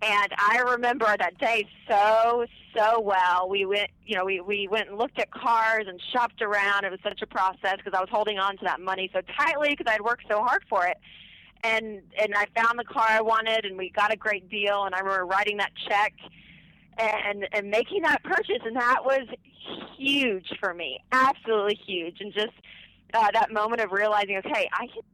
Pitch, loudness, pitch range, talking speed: 210 Hz, -25 LUFS, 195-225 Hz, 210 wpm